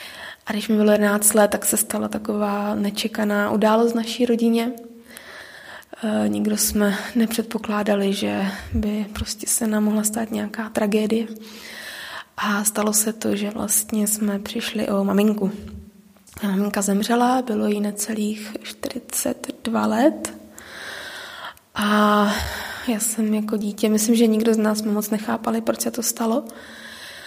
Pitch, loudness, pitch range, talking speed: 215 Hz, -21 LUFS, 205-230 Hz, 135 wpm